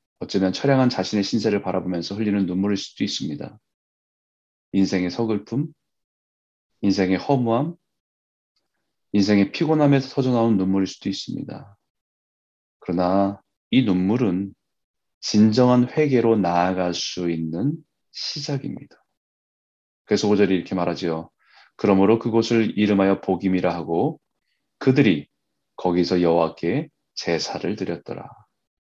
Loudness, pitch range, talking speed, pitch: -22 LUFS, 90-115 Hz, 275 characters per minute, 100 Hz